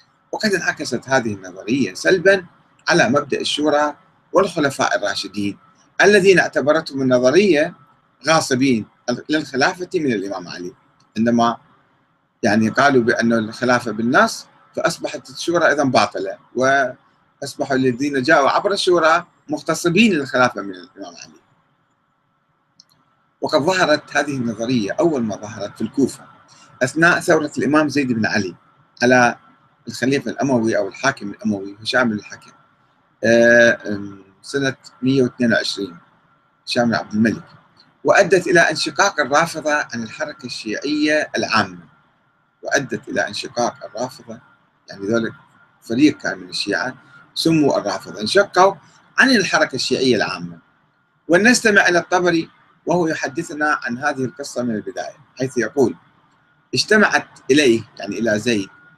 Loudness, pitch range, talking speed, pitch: -18 LUFS, 115-160 Hz, 110 wpm, 130 Hz